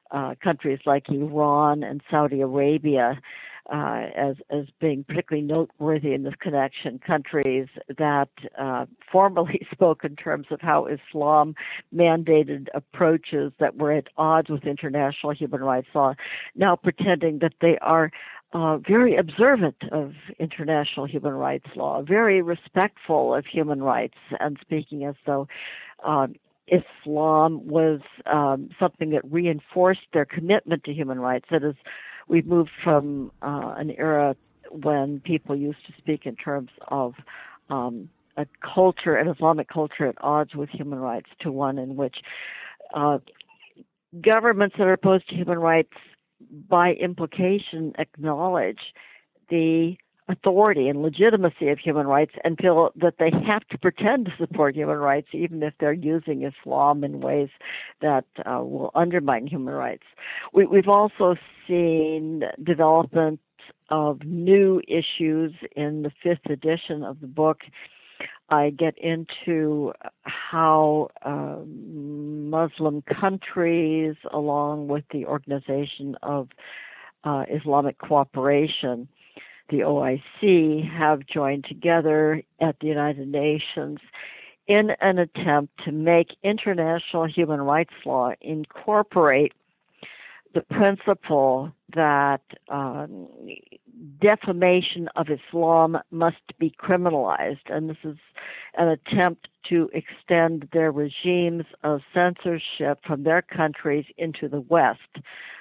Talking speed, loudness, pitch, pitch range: 125 wpm, -23 LUFS, 155 Hz, 145-170 Hz